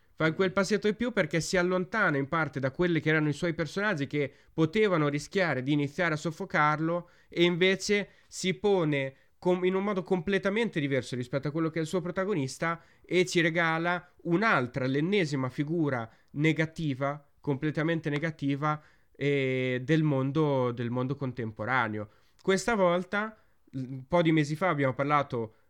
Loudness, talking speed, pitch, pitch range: -29 LUFS, 155 wpm, 160 Hz, 140-180 Hz